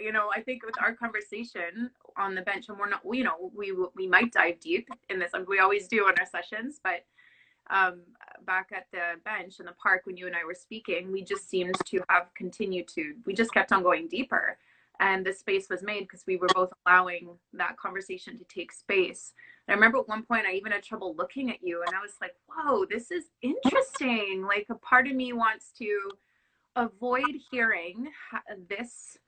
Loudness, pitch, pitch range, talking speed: -28 LUFS, 205 Hz, 185-240 Hz, 210 wpm